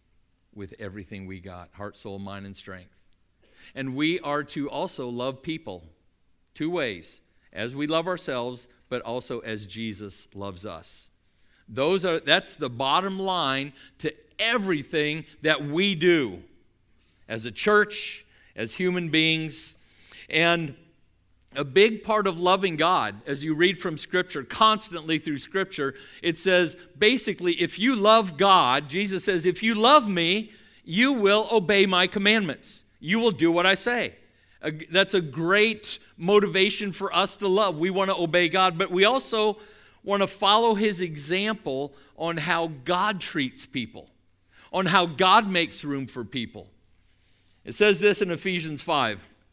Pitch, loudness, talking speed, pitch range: 165 Hz, -24 LUFS, 150 wpm, 120-195 Hz